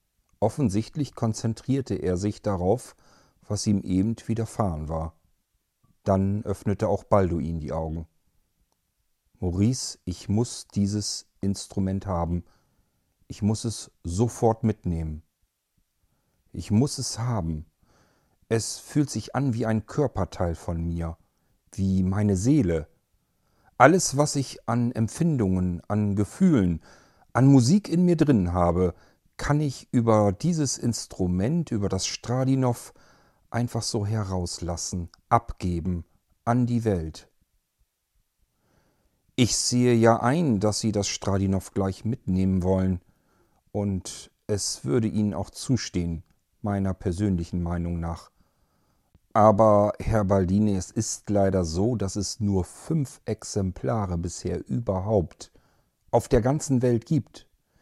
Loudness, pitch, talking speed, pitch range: -25 LUFS, 100 Hz, 115 wpm, 90-115 Hz